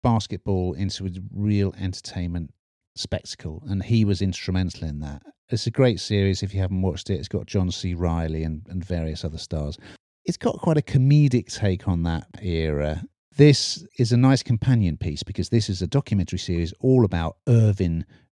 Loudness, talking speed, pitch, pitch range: -23 LUFS, 180 wpm, 95 Hz, 90-115 Hz